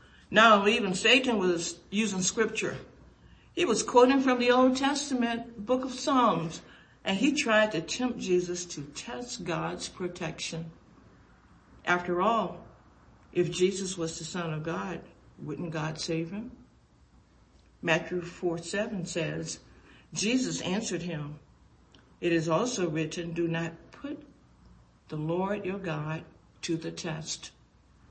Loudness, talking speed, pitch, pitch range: -29 LUFS, 125 wpm, 175 Hz, 165-220 Hz